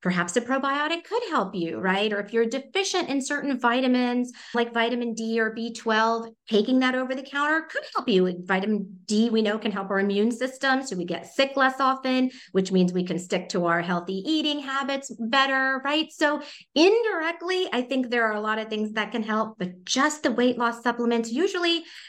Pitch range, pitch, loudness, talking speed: 210-275 Hz, 240 Hz, -25 LUFS, 200 wpm